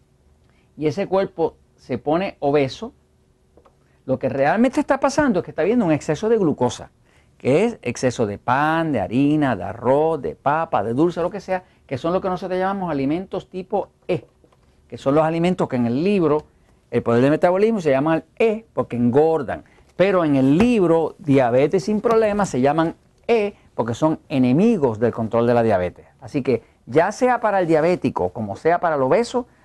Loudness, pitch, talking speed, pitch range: -20 LUFS, 160 Hz, 185 wpm, 130-195 Hz